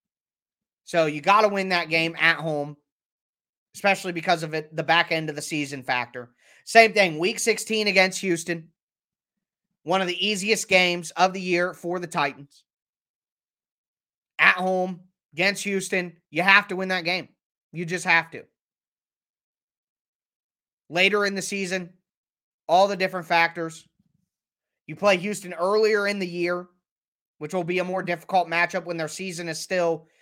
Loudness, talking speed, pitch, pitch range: -23 LUFS, 155 wpm, 180 Hz, 165-190 Hz